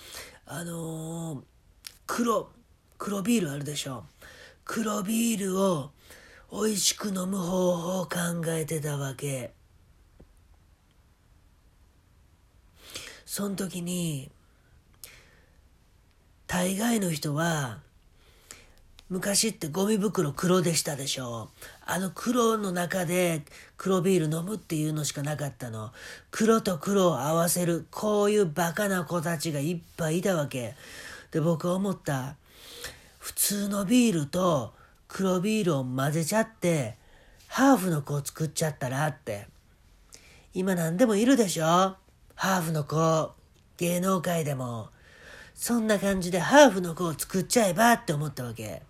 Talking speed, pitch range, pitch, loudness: 235 characters per minute, 135-190 Hz, 165 Hz, -27 LUFS